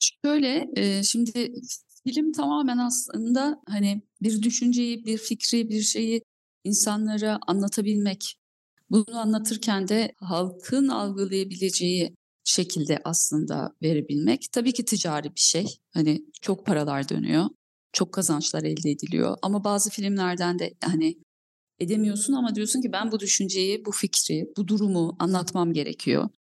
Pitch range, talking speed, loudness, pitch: 180-230 Hz, 120 wpm, -25 LUFS, 205 Hz